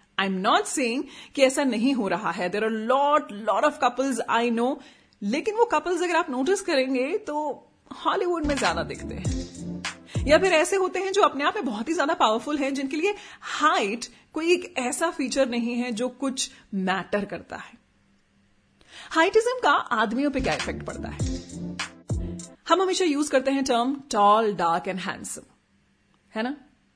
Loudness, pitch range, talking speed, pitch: -25 LUFS, 220-315 Hz, 175 wpm, 265 Hz